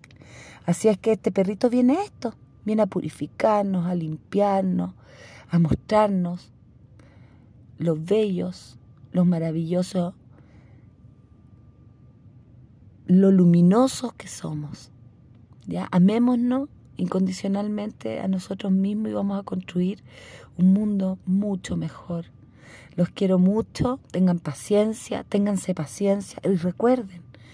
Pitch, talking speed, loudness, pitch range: 180 Hz, 100 wpm, -23 LUFS, 125-200 Hz